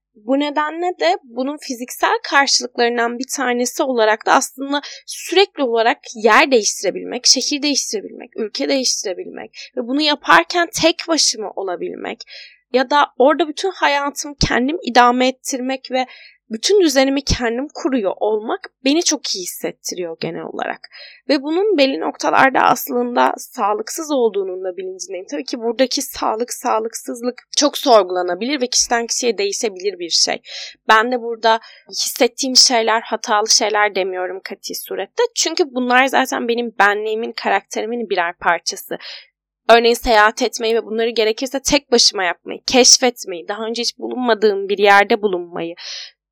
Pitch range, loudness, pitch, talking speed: 220-285 Hz, -17 LUFS, 245 Hz, 130 wpm